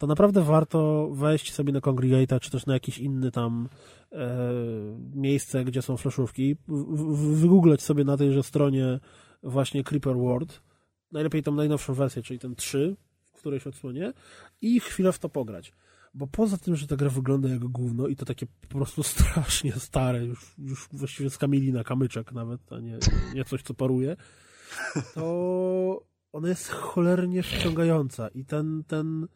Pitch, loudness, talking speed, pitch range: 140 Hz, -27 LUFS, 165 wpm, 130-155 Hz